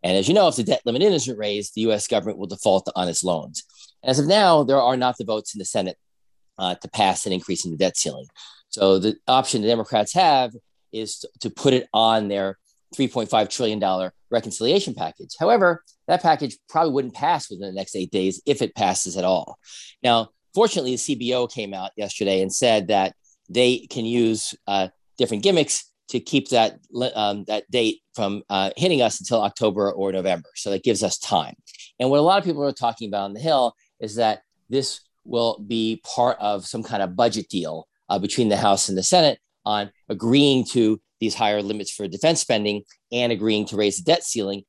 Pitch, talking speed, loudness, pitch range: 110 Hz, 205 wpm, -22 LUFS, 100-125 Hz